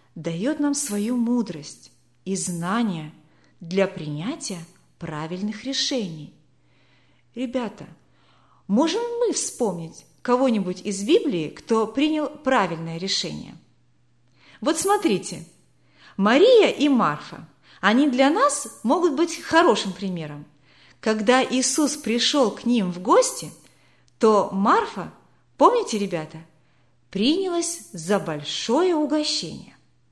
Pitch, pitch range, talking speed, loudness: 220 Hz, 170-285 Hz, 95 wpm, -22 LUFS